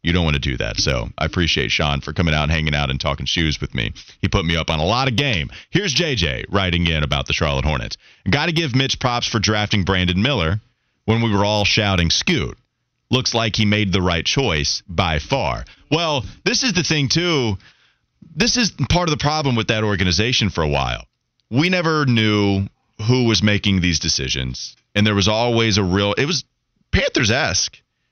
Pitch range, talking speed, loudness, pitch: 80-125 Hz, 210 wpm, -18 LUFS, 105 Hz